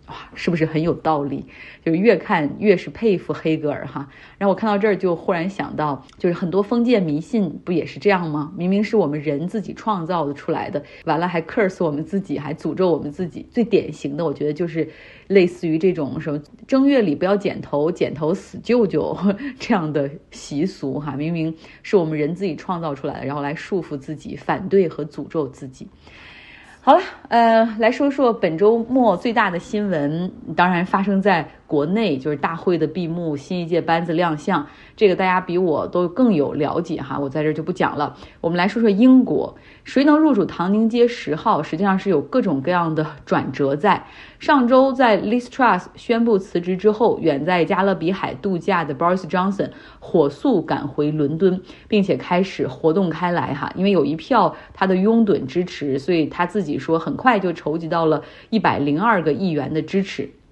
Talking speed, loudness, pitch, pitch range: 305 characters per minute, -20 LUFS, 175 Hz, 155-205 Hz